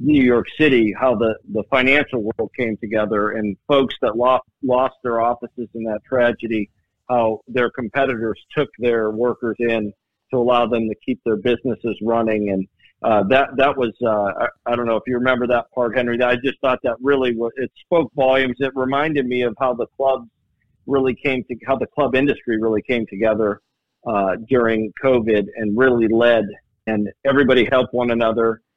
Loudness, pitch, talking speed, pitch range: -19 LUFS, 120 Hz, 185 wpm, 110-130 Hz